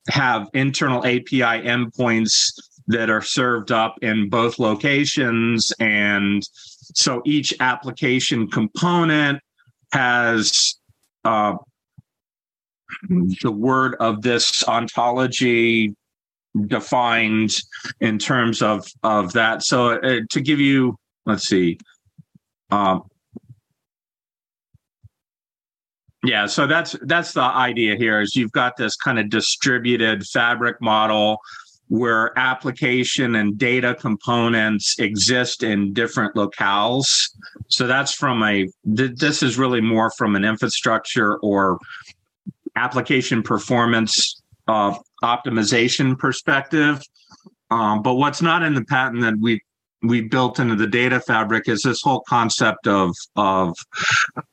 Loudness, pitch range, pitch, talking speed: -19 LUFS, 110-130 Hz, 120 Hz, 110 wpm